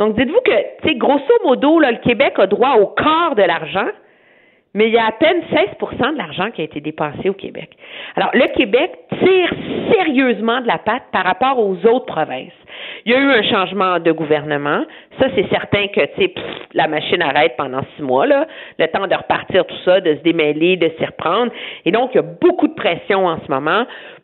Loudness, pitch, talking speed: -16 LUFS, 225 Hz, 210 wpm